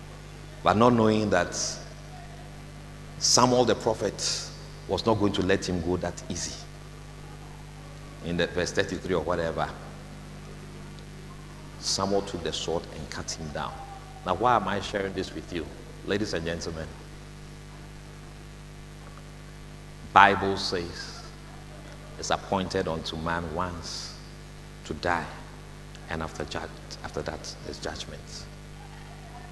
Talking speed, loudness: 110 wpm, -27 LUFS